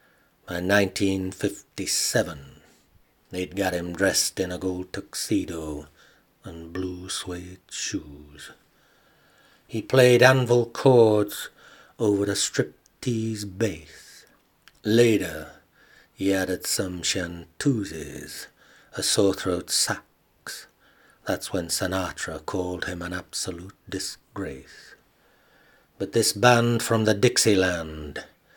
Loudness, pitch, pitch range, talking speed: -24 LUFS, 95 Hz, 90-110 Hz, 95 wpm